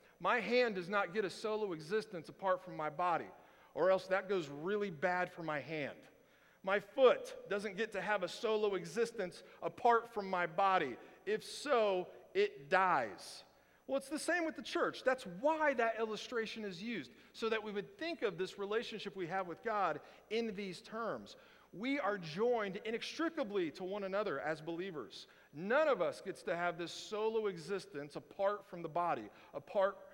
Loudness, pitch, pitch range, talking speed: -38 LUFS, 205 Hz, 185-230 Hz, 175 wpm